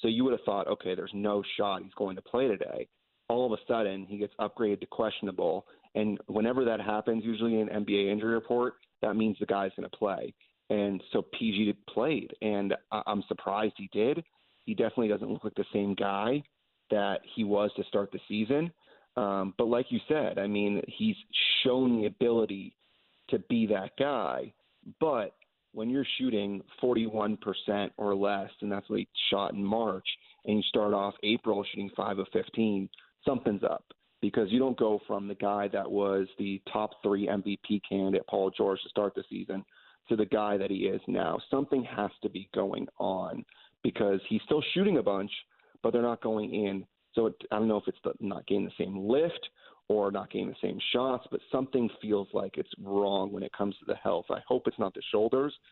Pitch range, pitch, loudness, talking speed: 100-115 Hz, 105 Hz, -31 LUFS, 200 wpm